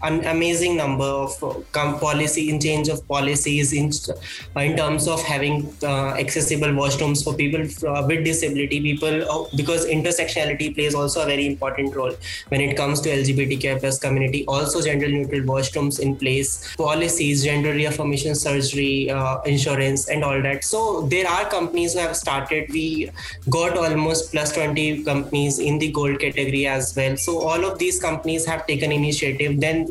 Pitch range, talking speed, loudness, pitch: 140-155 Hz, 170 wpm, -21 LUFS, 150 Hz